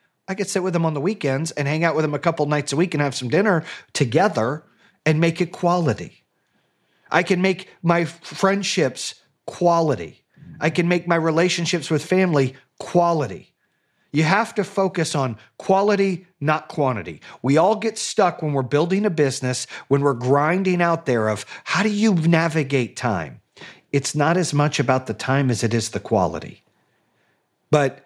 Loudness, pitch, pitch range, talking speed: -21 LUFS, 160 Hz, 140-180 Hz, 175 wpm